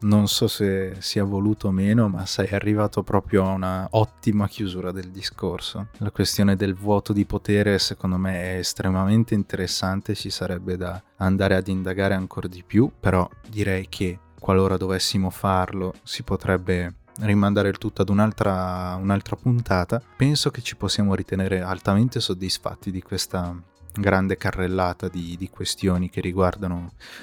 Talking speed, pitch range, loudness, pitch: 150 wpm, 95-105 Hz, -23 LUFS, 95 Hz